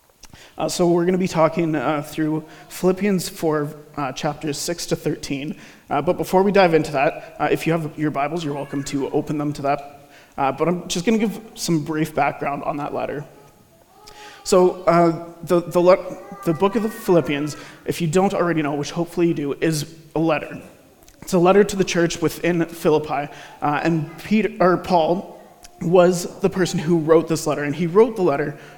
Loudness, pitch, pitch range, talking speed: -20 LUFS, 165 Hz, 150-180 Hz, 200 wpm